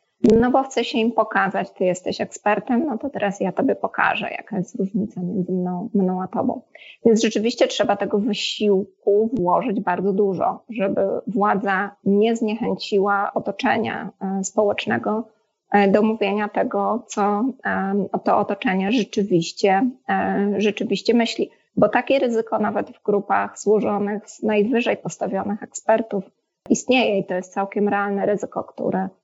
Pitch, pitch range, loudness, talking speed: 205 Hz, 200-225 Hz, -21 LUFS, 135 wpm